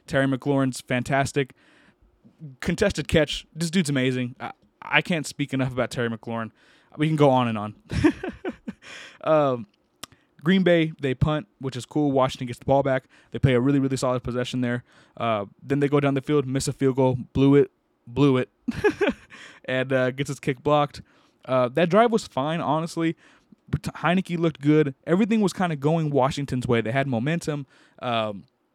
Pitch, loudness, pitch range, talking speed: 140 Hz, -24 LUFS, 125-155 Hz, 175 wpm